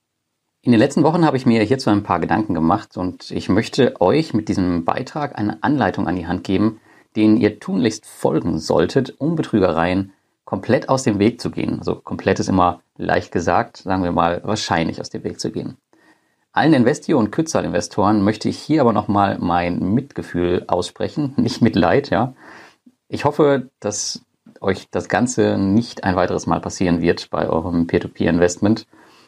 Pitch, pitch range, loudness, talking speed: 105 Hz, 90-115 Hz, -19 LUFS, 170 wpm